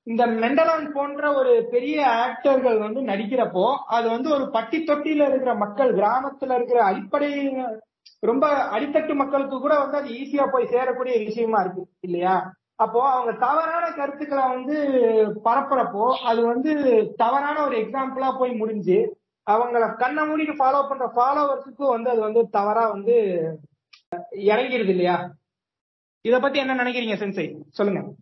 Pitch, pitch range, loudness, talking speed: 250 Hz, 220-280 Hz, -22 LUFS, 130 wpm